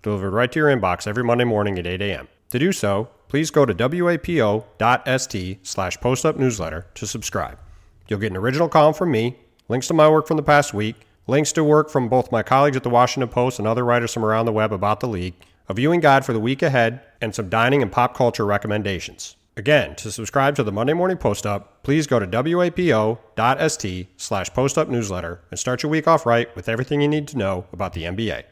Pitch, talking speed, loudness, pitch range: 115 Hz, 205 wpm, -20 LUFS, 105-140 Hz